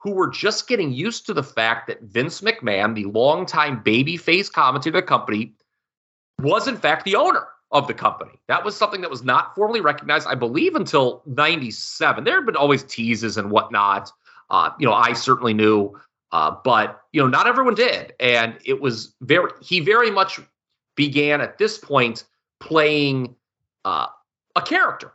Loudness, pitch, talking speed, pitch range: -19 LUFS, 135 Hz, 170 wpm, 115-175 Hz